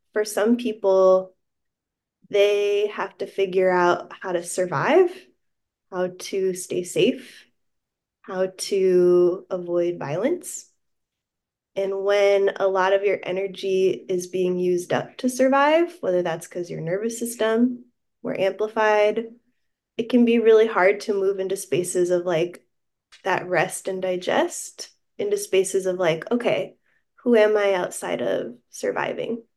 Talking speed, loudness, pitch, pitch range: 135 wpm, -22 LUFS, 195 Hz, 185-230 Hz